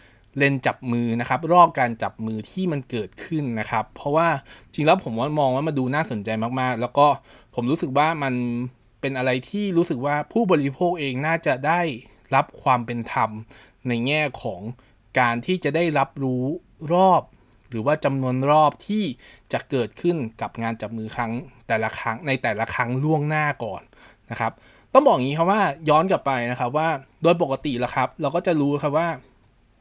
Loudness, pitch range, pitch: -23 LUFS, 120-155 Hz, 130 Hz